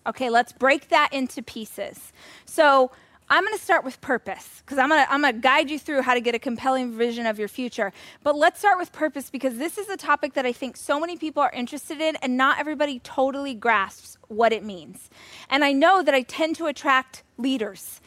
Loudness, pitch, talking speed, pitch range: -23 LUFS, 270 Hz, 215 wpm, 245-305 Hz